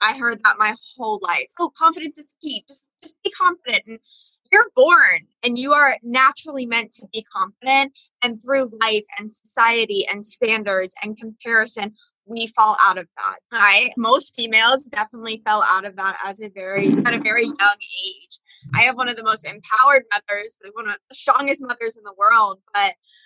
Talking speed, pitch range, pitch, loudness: 190 wpm, 215-275 Hz, 230 Hz, -18 LUFS